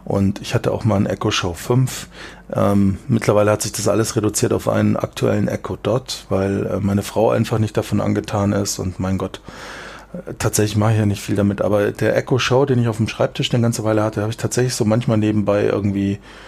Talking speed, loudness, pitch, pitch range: 210 wpm, -19 LUFS, 105 Hz, 100-115 Hz